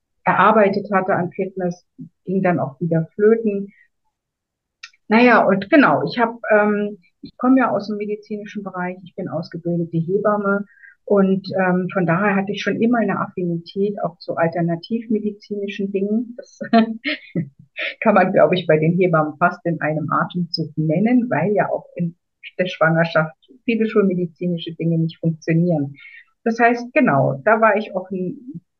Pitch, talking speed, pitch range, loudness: 195 Hz, 150 wpm, 170-215 Hz, -19 LUFS